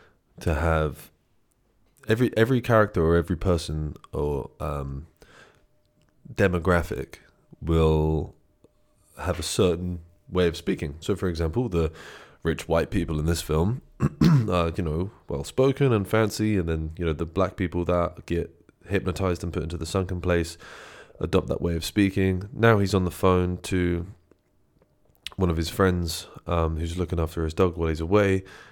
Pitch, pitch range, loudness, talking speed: 90 Hz, 80-95 Hz, -25 LUFS, 155 wpm